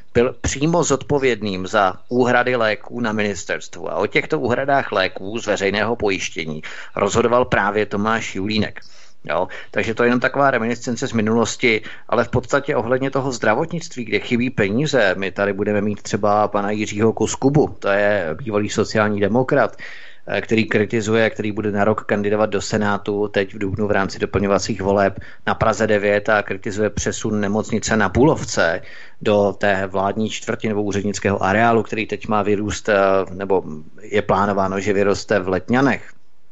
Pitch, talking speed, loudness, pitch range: 105 Hz, 155 wpm, -19 LUFS, 100-115 Hz